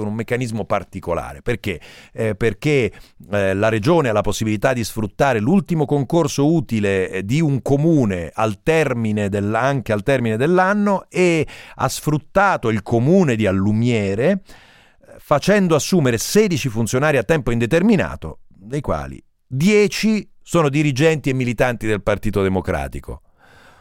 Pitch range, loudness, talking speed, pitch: 105-160 Hz, -18 LUFS, 125 wpm, 125 Hz